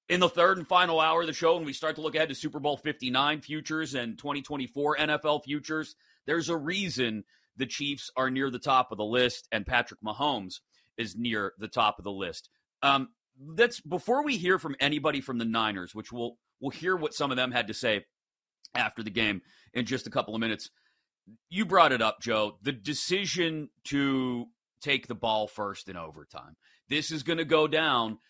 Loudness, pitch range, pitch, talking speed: -29 LUFS, 115-155 Hz, 140 Hz, 205 wpm